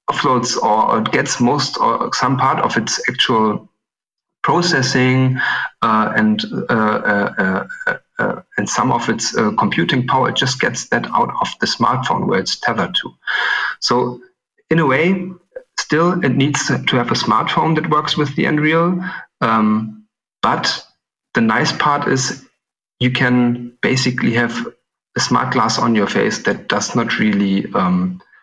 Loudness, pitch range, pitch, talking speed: -16 LUFS, 120-175 Hz, 140 Hz, 155 wpm